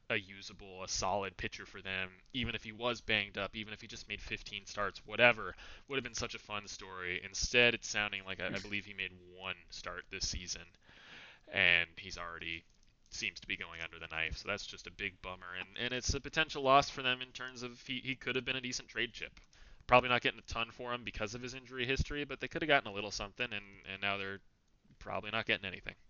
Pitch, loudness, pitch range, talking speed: 105 Hz, -36 LUFS, 95-120 Hz, 240 wpm